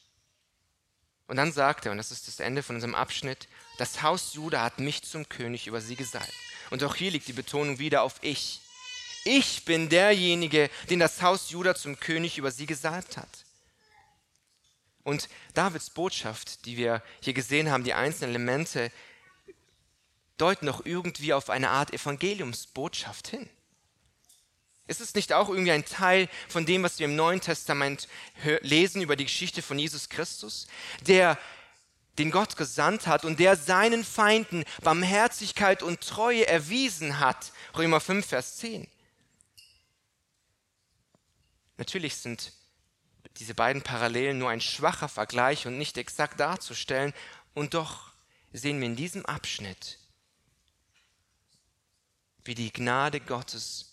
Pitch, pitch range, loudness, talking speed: 150 Hz, 120-175 Hz, -28 LUFS, 140 wpm